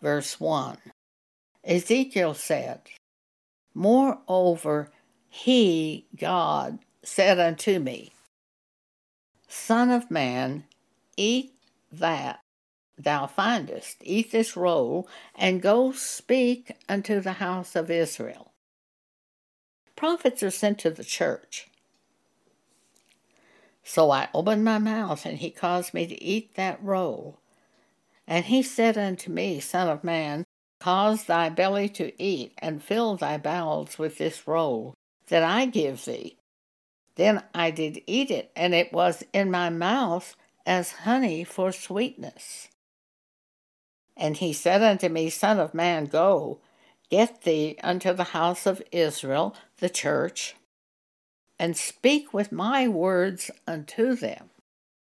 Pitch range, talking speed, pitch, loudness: 165-220 Hz, 120 wpm, 180 Hz, -25 LUFS